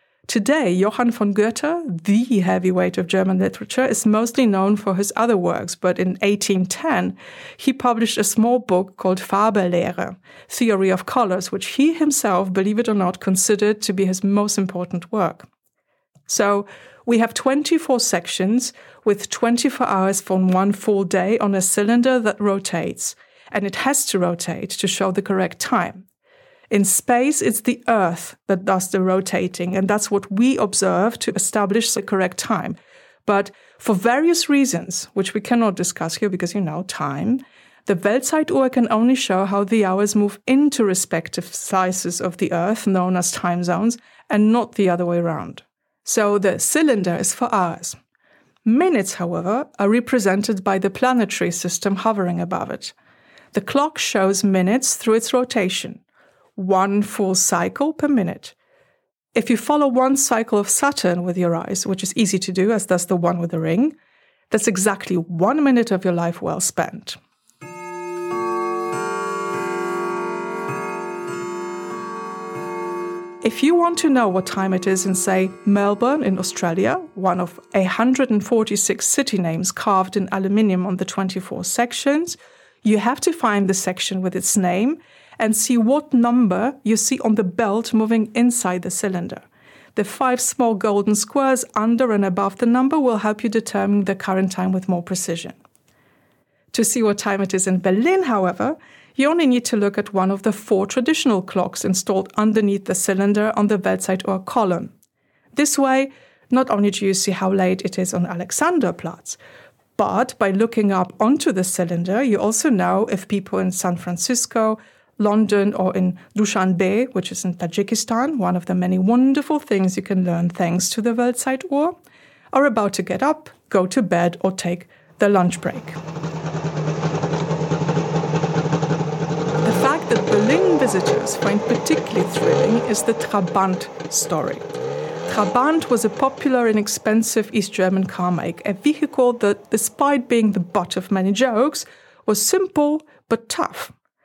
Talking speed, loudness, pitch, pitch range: 160 wpm, -19 LUFS, 205 Hz, 185-240 Hz